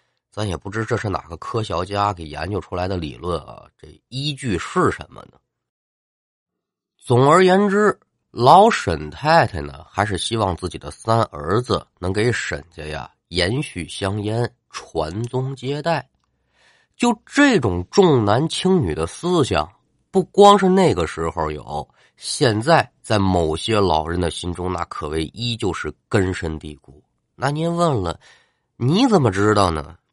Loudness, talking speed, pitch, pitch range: -19 LUFS, 215 characters per minute, 100 Hz, 80-130 Hz